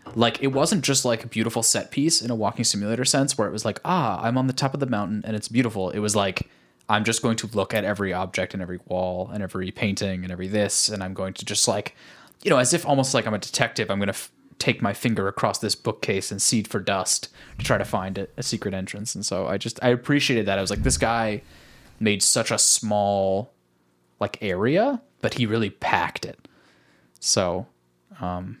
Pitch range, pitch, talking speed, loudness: 95-120 Hz, 105 Hz, 235 wpm, -23 LUFS